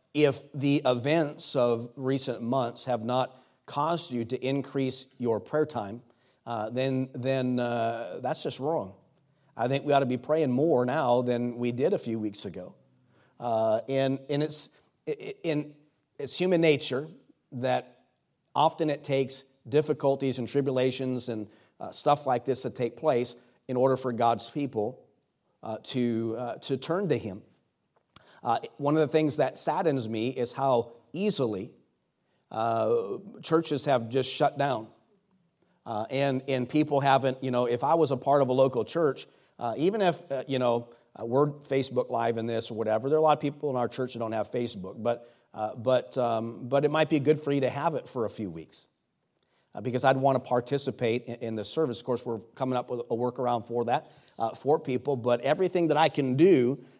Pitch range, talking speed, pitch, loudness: 120-145 Hz, 190 wpm, 130 Hz, -28 LUFS